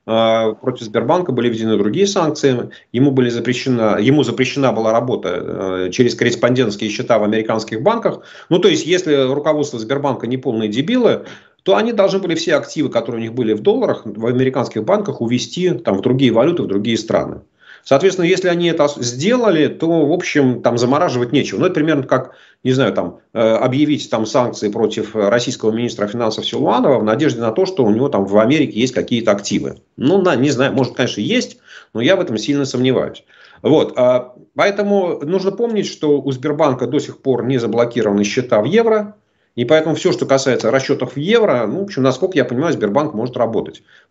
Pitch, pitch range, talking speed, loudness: 130 Hz, 115-155 Hz, 180 wpm, -16 LUFS